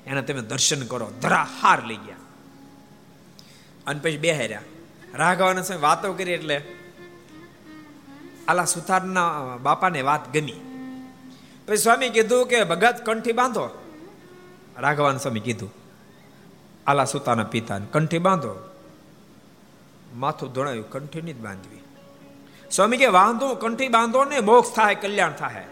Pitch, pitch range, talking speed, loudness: 170 Hz, 135-215 Hz, 105 wpm, -22 LUFS